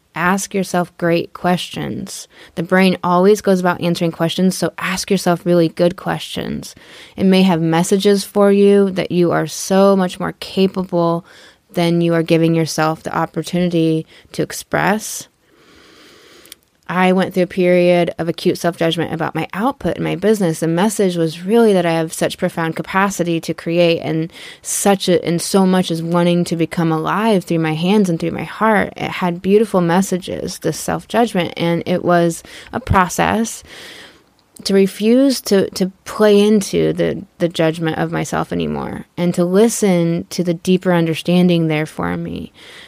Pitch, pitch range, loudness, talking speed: 175 Hz, 165-190 Hz, -16 LUFS, 160 wpm